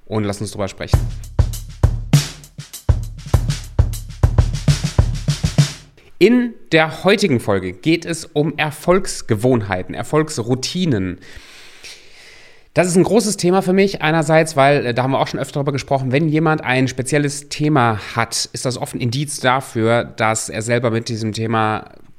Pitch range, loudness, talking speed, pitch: 110-155 Hz, -18 LUFS, 135 wpm, 135 Hz